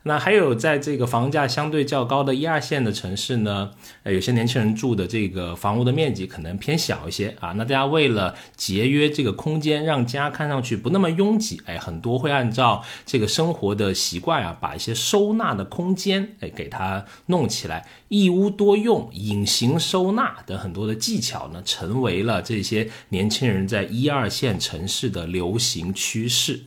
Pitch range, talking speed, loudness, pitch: 100-150 Hz, 280 characters per minute, -22 LUFS, 120 Hz